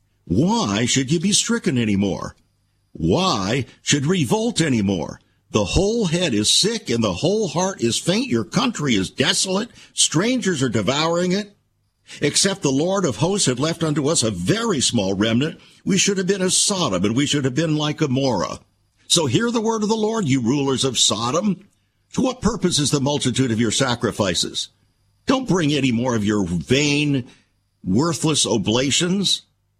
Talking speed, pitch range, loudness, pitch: 175 wpm, 115-185 Hz, -19 LUFS, 145 Hz